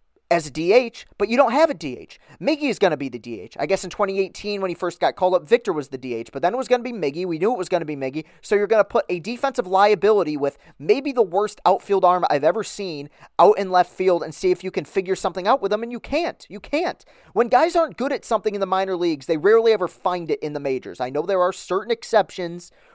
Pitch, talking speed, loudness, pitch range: 190 Hz, 275 wpm, -21 LUFS, 170-220 Hz